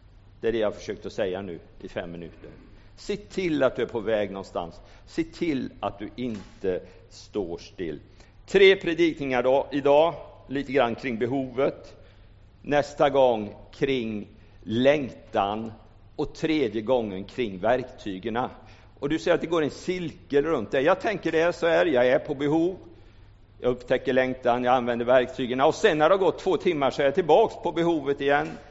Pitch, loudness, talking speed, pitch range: 130 Hz, -25 LUFS, 170 wpm, 110-150 Hz